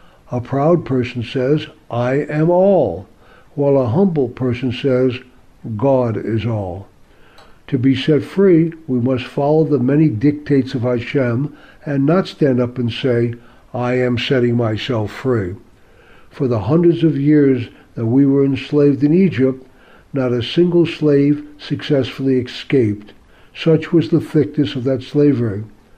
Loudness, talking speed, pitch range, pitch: -16 LUFS, 145 wpm, 120-150 Hz, 135 Hz